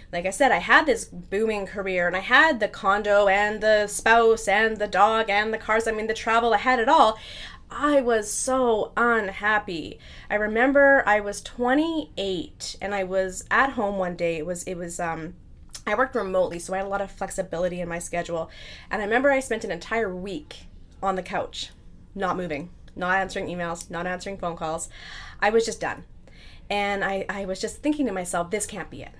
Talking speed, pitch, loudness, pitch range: 210 wpm, 205 Hz, -23 LUFS, 185-225 Hz